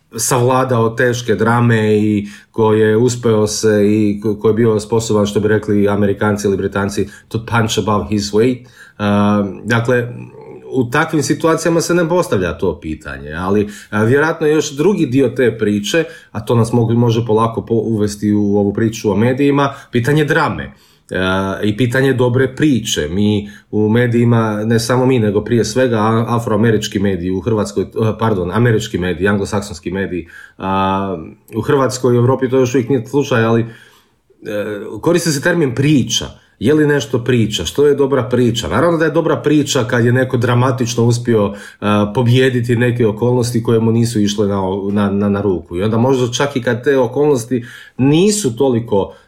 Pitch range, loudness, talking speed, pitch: 105-130 Hz, -15 LUFS, 160 wpm, 115 Hz